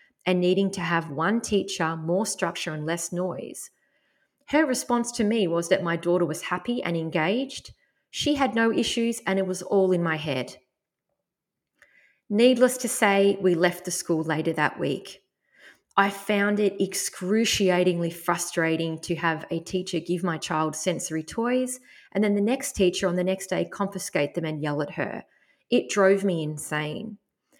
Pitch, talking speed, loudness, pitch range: 190 Hz, 165 wpm, -25 LUFS, 170-225 Hz